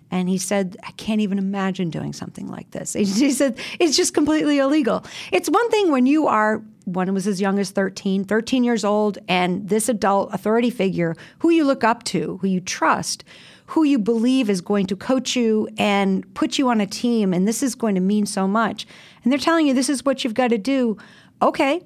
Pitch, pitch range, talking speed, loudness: 220 Hz, 195-270 Hz, 220 wpm, -20 LUFS